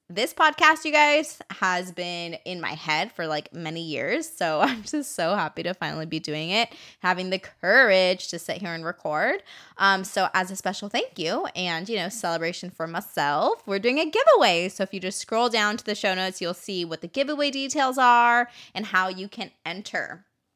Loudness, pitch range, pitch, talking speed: -24 LUFS, 175-240 Hz, 190 Hz, 205 wpm